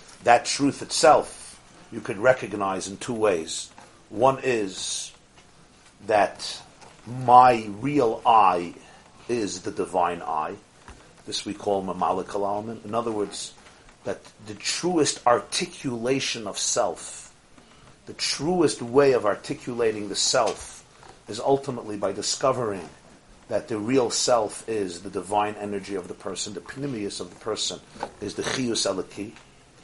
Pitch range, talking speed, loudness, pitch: 100-135 Hz, 125 wpm, -24 LUFS, 115 Hz